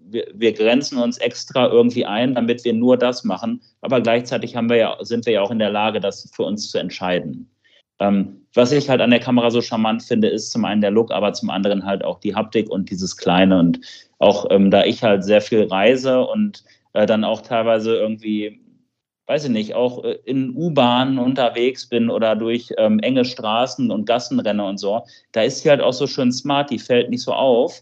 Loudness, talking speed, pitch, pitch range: -18 LUFS, 215 wpm, 115 Hz, 105-125 Hz